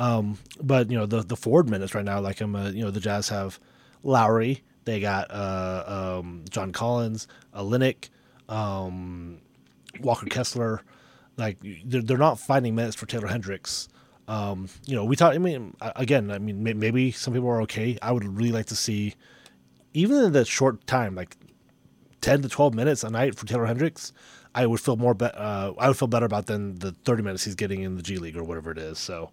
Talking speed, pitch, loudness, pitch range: 205 wpm, 110 Hz, -26 LUFS, 100-125 Hz